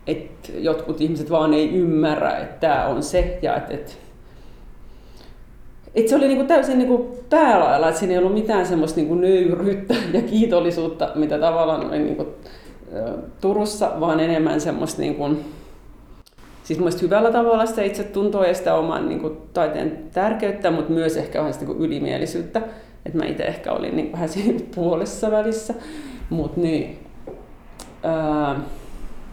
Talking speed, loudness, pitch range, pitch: 140 wpm, -21 LUFS, 160-215 Hz, 175 Hz